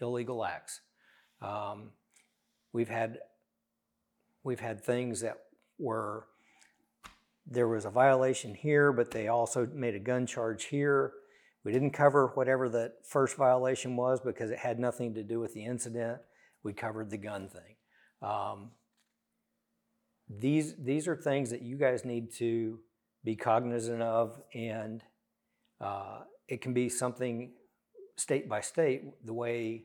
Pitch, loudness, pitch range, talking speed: 120 Hz, -33 LUFS, 115-130 Hz, 140 wpm